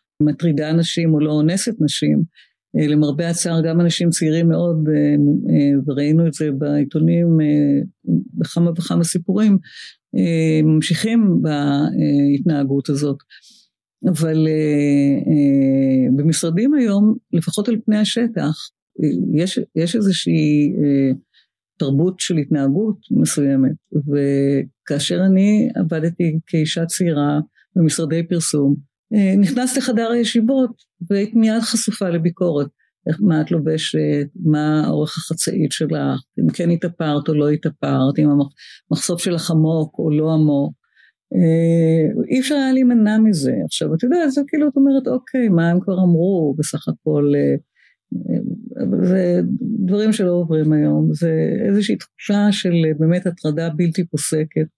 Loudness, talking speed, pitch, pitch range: -17 LUFS, 110 wpm, 165 Hz, 150-190 Hz